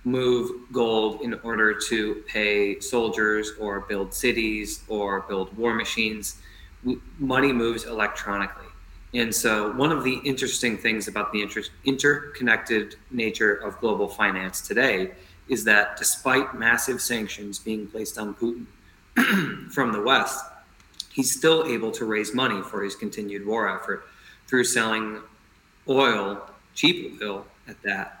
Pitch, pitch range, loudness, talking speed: 110 Hz, 100-120 Hz, -24 LUFS, 135 wpm